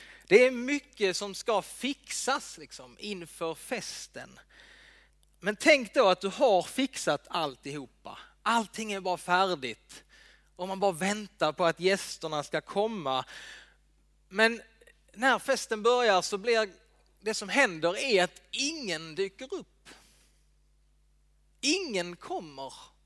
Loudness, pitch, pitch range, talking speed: -29 LUFS, 195 Hz, 175-240 Hz, 120 wpm